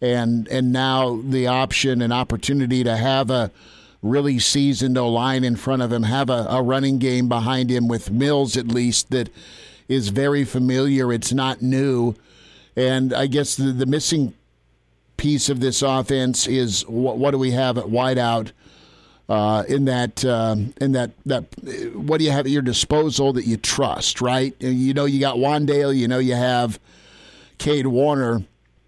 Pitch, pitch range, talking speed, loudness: 130 Hz, 120-135 Hz, 170 wpm, -20 LUFS